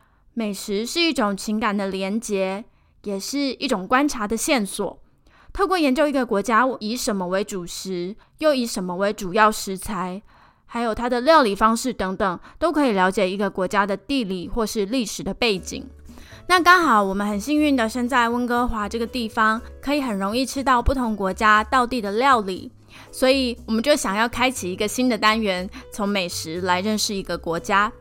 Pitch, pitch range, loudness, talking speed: 220 Hz, 195-250 Hz, -21 LUFS, 280 characters per minute